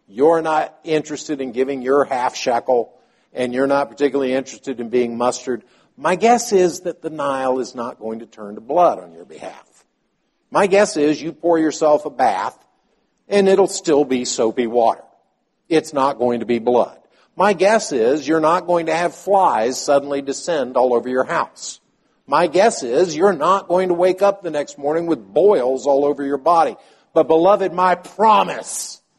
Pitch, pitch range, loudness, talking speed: 145 Hz, 130-175 Hz, -18 LUFS, 185 wpm